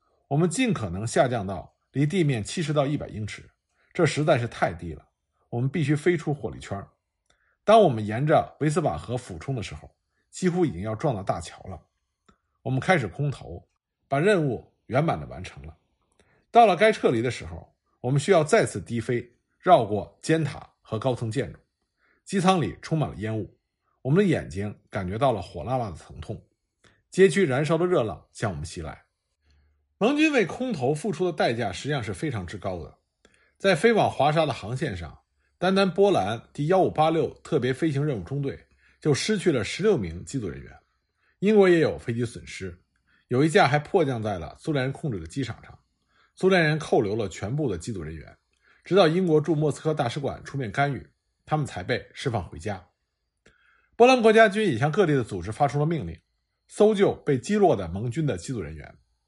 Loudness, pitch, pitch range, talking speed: -25 LUFS, 135 Hz, 100-165 Hz, 285 characters per minute